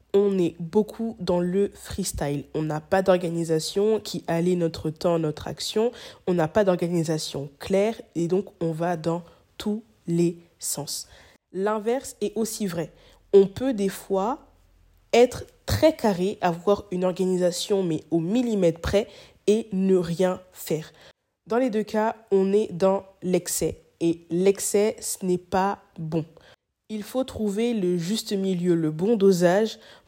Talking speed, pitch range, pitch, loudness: 150 wpm, 170-210 Hz, 185 Hz, -25 LUFS